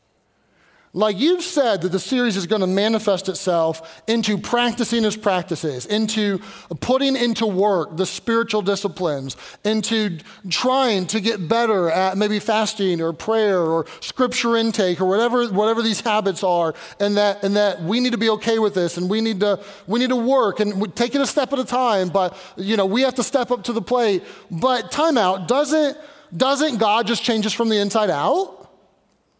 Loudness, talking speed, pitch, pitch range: -20 LUFS, 185 wpm, 215 Hz, 190-235 Hz